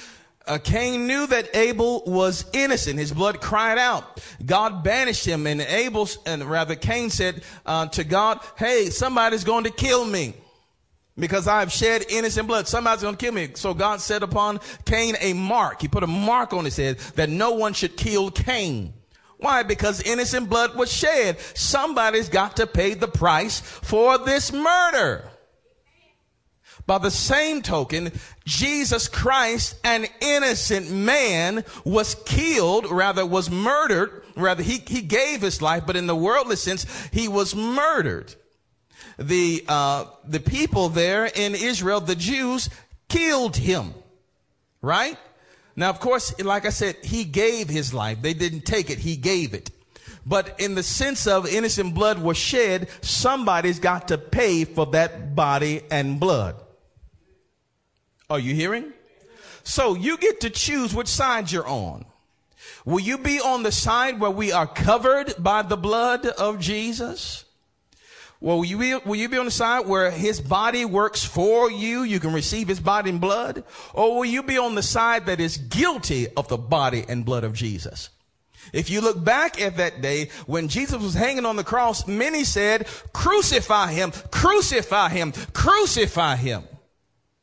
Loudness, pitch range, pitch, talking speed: -22 LUFS, 170-235 Hz, 205 Hz, 165 wpm